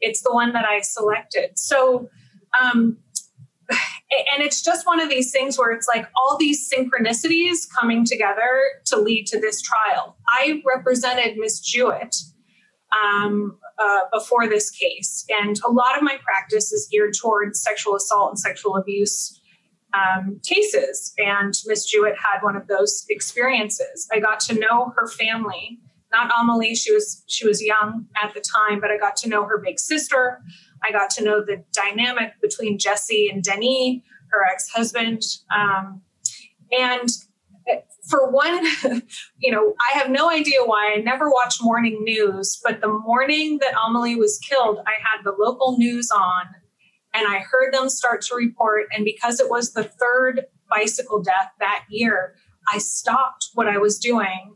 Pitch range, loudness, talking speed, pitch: 205-255 Hz, -20 LUFS, 165 wpm, 225 Hz